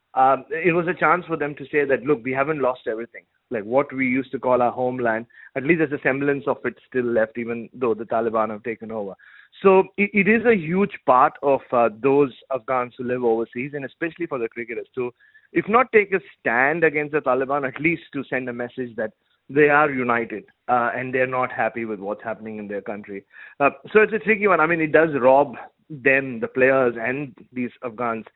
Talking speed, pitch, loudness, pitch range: 220 wpm, 130 Hz, -21 LUFS, 120-155 Hz